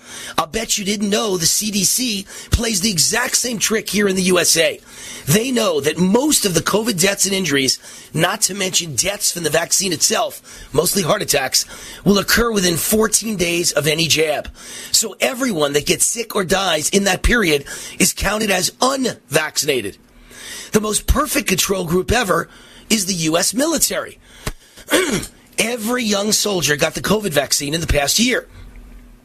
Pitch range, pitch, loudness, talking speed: 170-220 Hz, 195 Hz, -17 LUFS, 165 wpm